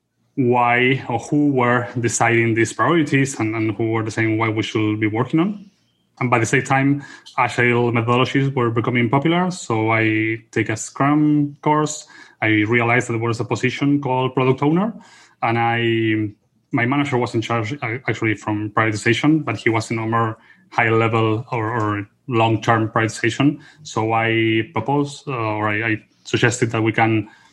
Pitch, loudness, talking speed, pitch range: 115 Hz, -19 LUFS, 170 wpm, 110-135 Hz